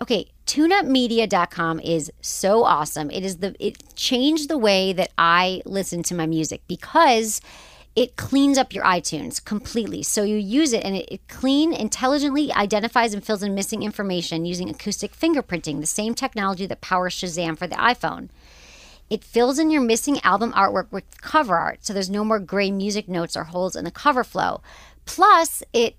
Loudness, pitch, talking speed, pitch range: -21 LUFS, 205 Hz, 180 wpm, 180-245 Hz